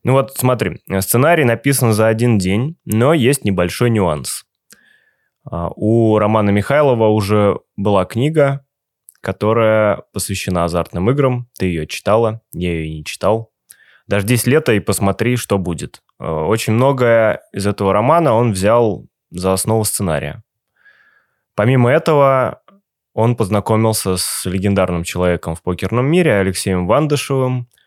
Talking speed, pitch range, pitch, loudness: 125 wpm, 95-125 Hz, 110 Hz, -16 LUFS